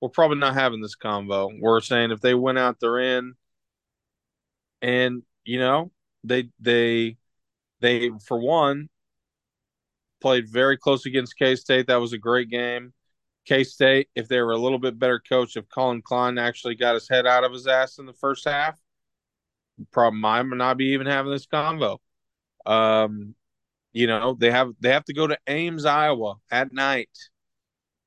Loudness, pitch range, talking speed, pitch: -22 LUFS, 120-135 Hz, 170 wpm, 125 Hz